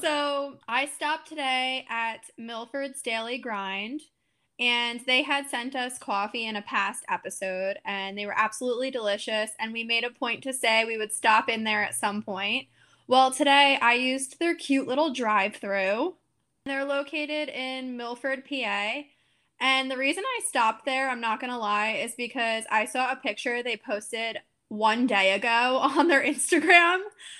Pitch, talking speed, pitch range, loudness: 250 Hz, 170 wpm, 220-275 Hz, -26 LUFS